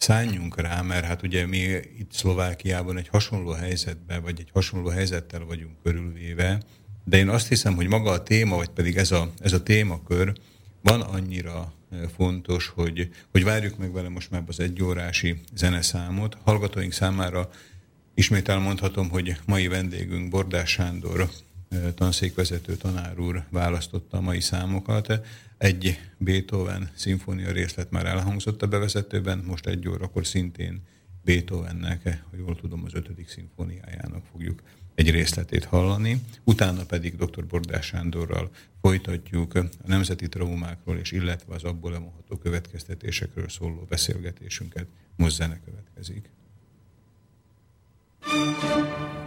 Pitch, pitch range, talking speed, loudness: 90 Hz, 85-100 Hz, 130 wpm, -26 LUFS